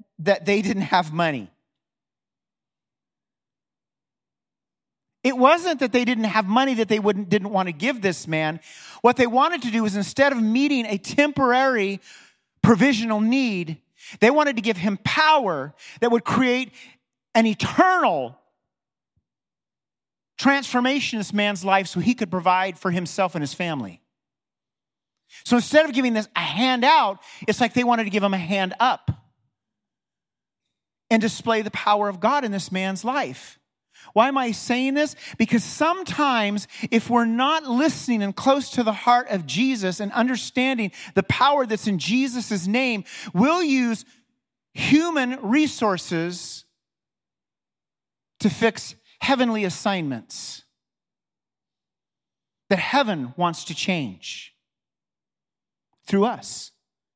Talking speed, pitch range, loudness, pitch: 135 wpm, 195-255 Hz, -21 LUFS, 225 Hz